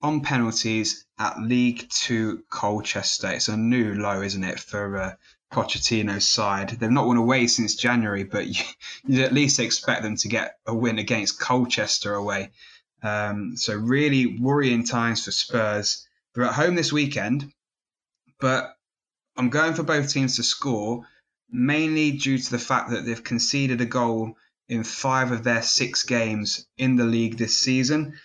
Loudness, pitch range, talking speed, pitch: -23 LUFS, 110-130 Hz, 165 wpm, 120 Hz